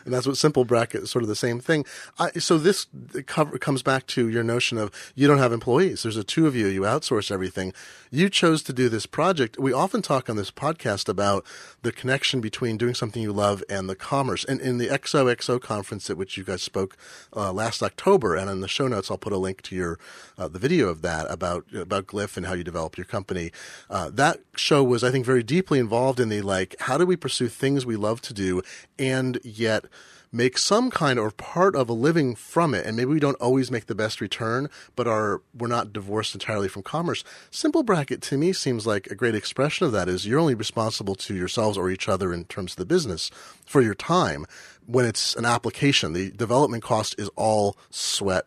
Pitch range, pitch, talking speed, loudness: 105-135 Hz, 120 Hz, 230 wpm, -24 LUFS